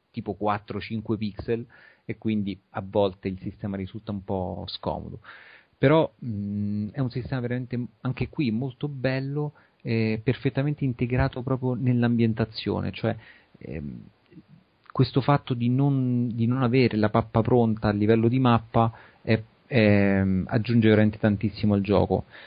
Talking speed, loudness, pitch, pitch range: 135 wpm, -25 LUFS, 115 Hz, 105-125 Hz